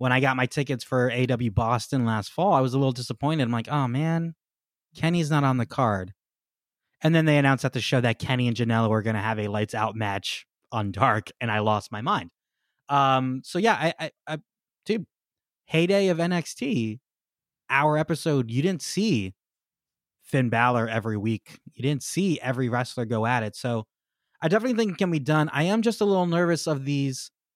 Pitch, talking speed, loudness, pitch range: 135 Hz, 205 wpm, -25 LUFS, 115-160 Hz